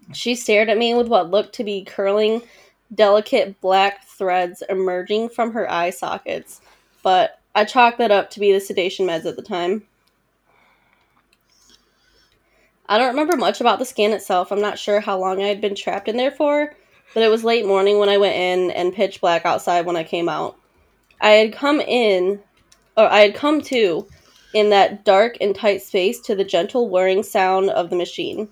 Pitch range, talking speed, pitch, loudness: 190-230 Hz, 190 wpm, 205 Hz, -18 LUFS